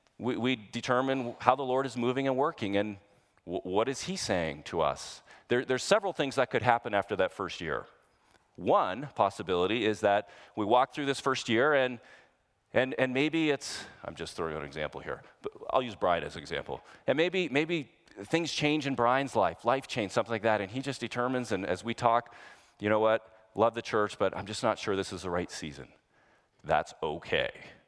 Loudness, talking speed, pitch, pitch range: -30 LUFS, 205 wpm, 125 Hz, 110-140 Hz